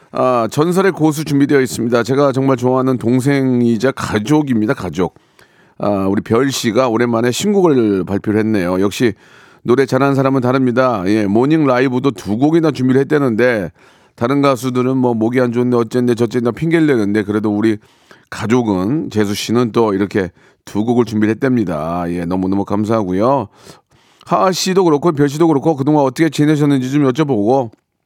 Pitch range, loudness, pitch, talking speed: 110-140 Hz, -15 LUFS, 125 Hz, 370 characters per minute